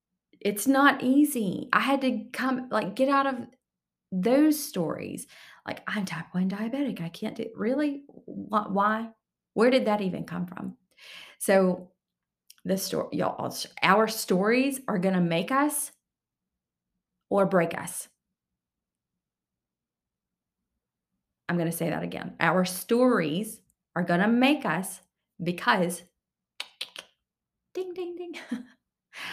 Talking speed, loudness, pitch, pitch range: 115 wpm, -27 LUFS, 215 Hz, 180-260 Hz